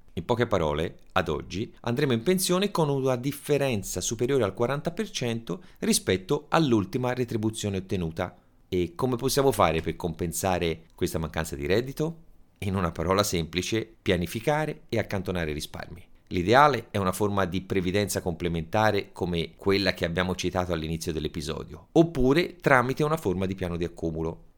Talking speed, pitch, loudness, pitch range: 140 wpm, 100 Hz, -27 LUFS, 90-130 Hz